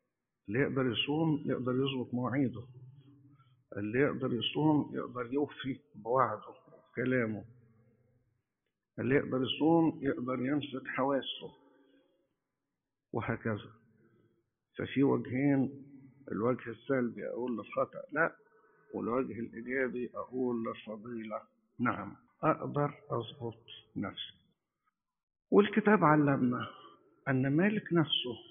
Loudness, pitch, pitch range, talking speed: -33 LUFS, 125 Hz, 115-140 Hz, 85 wpm